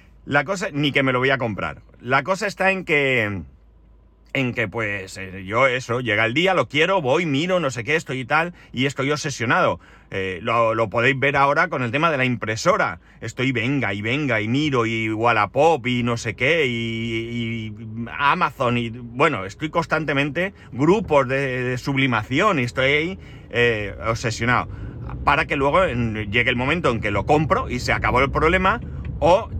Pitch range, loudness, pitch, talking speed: 115-145 Hz, -20 LUFS, 125 Hz, 185 wpm